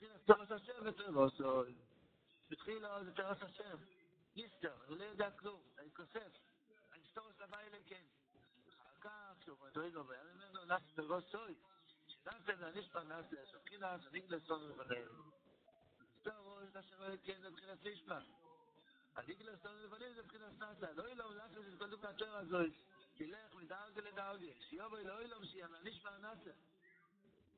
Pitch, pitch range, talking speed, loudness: 200 Hz, 170-215 Hz, 160 wpm, -46 LUFS